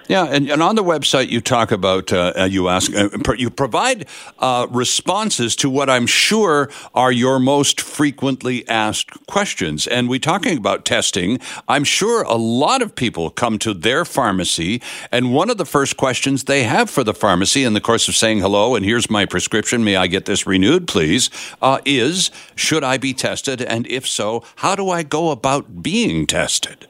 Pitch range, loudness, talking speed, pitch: 110-140 Hz, -17 LUFS, 190 wpm, 125 Hz